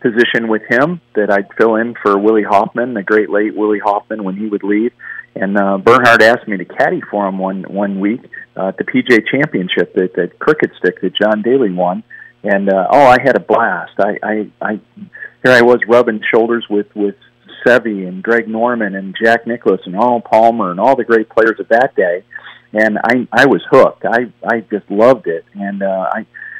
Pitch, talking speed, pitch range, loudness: 110 Hz, 210 wpm, 100-115 Hz, -13 LUFS